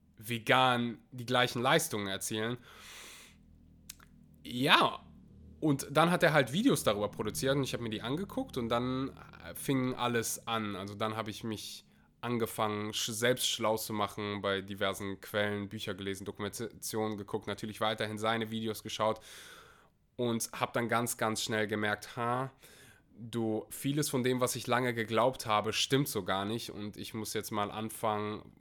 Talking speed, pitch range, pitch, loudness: 155 wpm, 105-125 Hz, 110 Hz, -33 LUFS